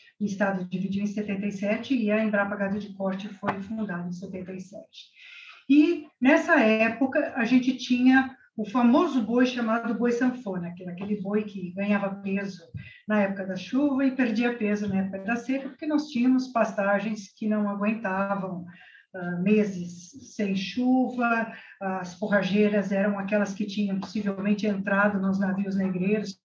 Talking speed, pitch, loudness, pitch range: 145 wpm, 205 Hz, -26 LUFS, 195-240 Hz